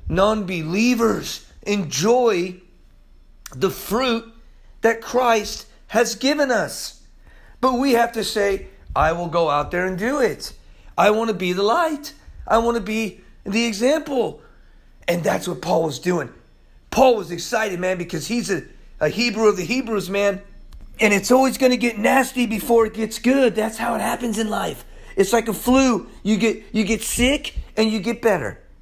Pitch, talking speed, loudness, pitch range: 220 Hz, 175 wpm, -20 LUFS, 195-240 Hz